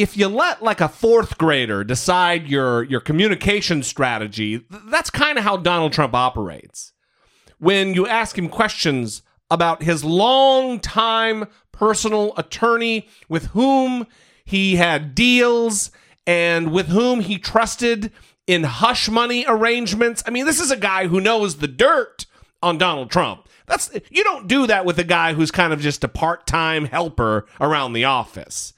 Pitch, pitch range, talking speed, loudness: 185 Hz, 160-225 Hz, 155 wpm, -18 LUFS